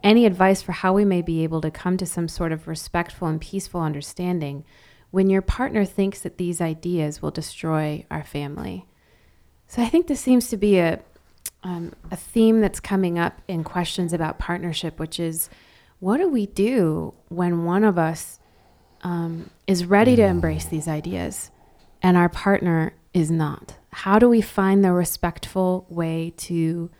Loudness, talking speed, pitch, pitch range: -22 LUFS, 170 wpm, 175 Hz, 160-195 Hz